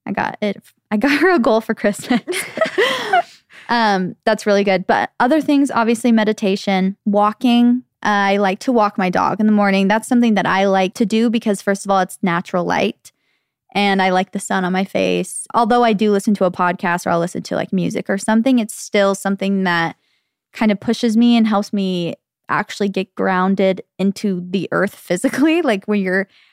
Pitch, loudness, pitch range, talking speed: 205 Hz, -17 LUFS, 190-230 Hz, 200 wpm